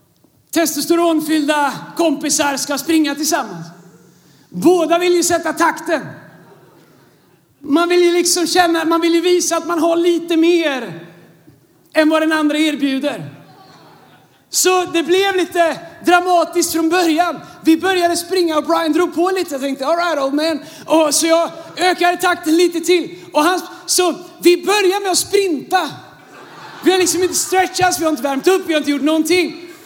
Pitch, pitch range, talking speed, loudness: 335 Hz, 305-350 Hz, 160 wpm, -15 LUFS